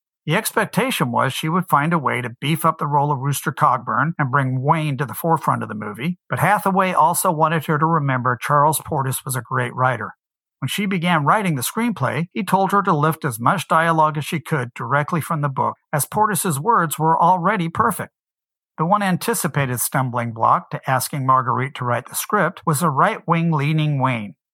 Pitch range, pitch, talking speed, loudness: 130-170 Hz, 155 Hz, 205 wpm, -19 LUFS